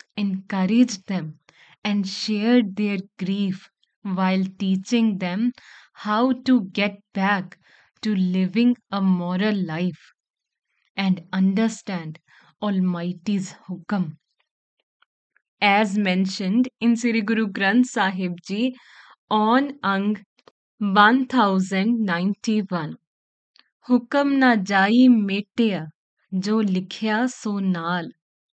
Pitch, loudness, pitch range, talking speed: 200 Hz, -22 LUFS, 185-225 Hz, 85 wpm